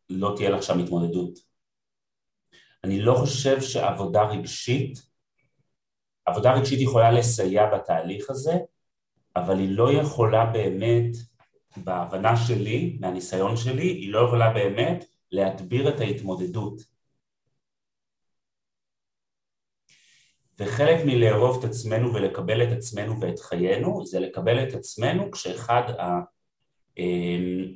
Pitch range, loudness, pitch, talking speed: 95-125 Hz, -24 LUFS, 115 Hz, 100 wpm